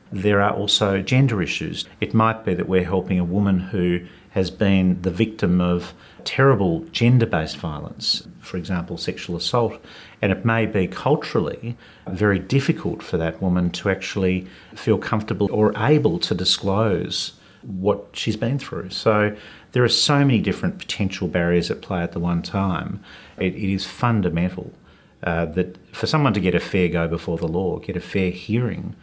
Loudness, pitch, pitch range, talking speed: -21 LUFS, 100 Hz, 90-110 Hz, 170 wpm